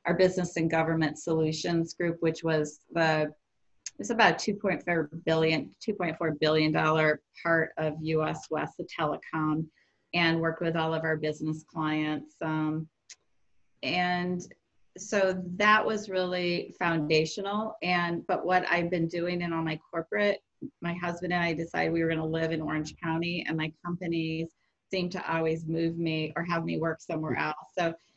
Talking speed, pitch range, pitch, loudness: 160 wpm, 155-175 Hz, 165 Hz, -29 LUFS